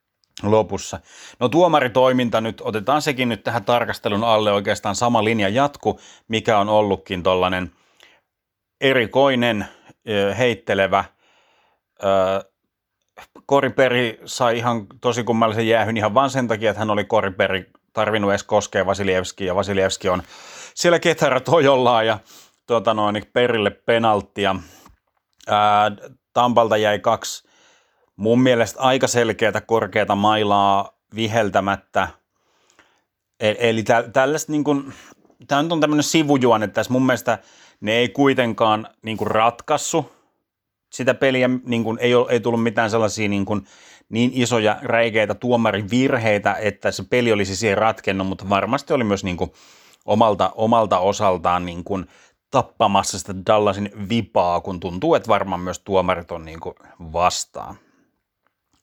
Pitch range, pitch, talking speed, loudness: 100-120 Hz, 110 Hz, 120 wpm, -19 LUFS